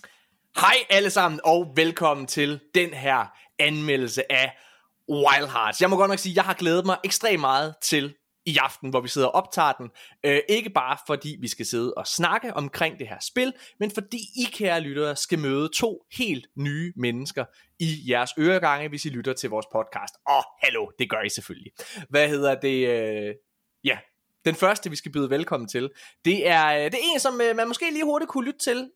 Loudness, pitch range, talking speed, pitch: -24 LUFS, 135-195 Hz, 205 wpm, 155 Hz